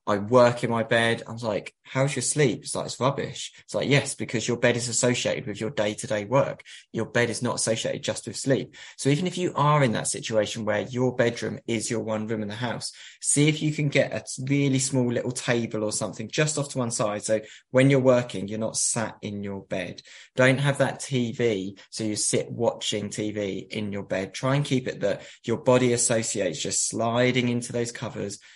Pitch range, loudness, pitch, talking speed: 110-130 Hz, -25 LUFS, 120 Hz, 220 wpm